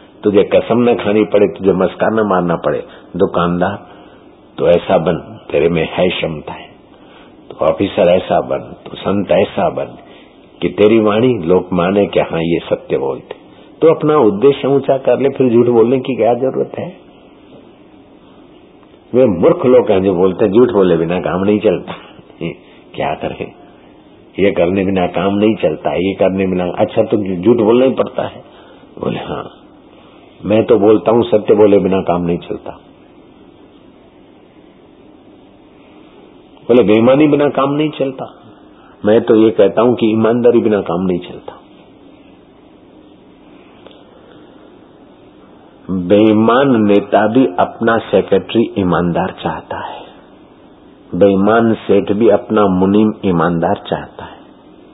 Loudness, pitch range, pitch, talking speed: -13 LUFS, 95-120 Hz, 105 Hz, 135 wpm